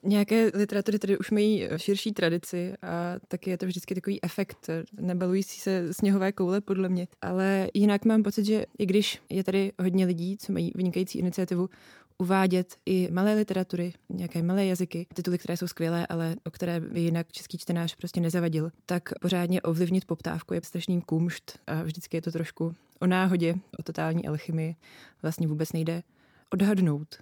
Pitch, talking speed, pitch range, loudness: 180 Hz, 170 wpm, 170-195 Hz, -28 LUFS